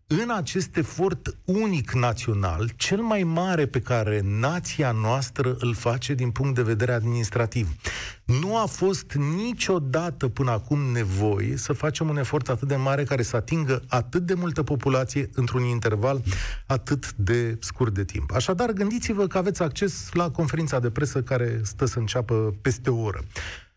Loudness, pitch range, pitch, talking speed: -25 LUFS, 115-160 Hz, 130 Hz, 160 wpm